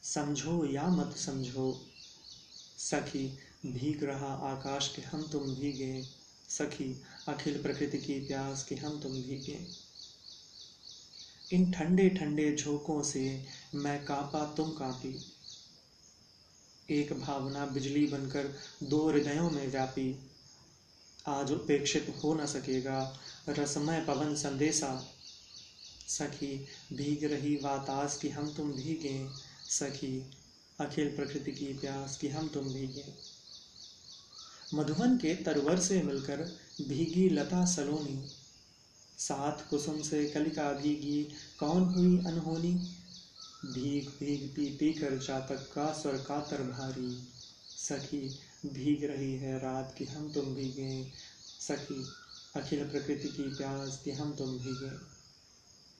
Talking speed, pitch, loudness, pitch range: 115 wpm, 145 Hz, -35 LUFS, 135-150 Hz